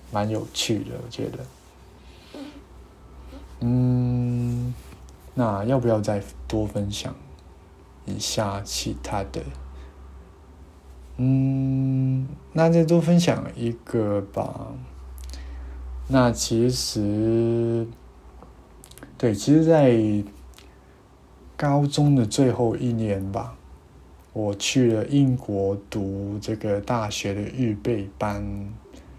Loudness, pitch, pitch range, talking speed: -24 LUFS, 105 Hz, 80-125 Hz, 120 characters per minute